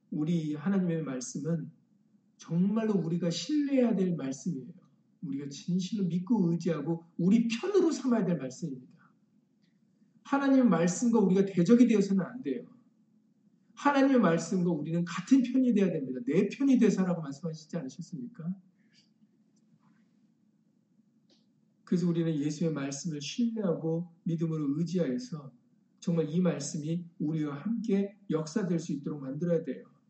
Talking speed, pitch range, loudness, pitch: 315 characters per minute, 165-220 Hz, -30 LUFS, 195 Hz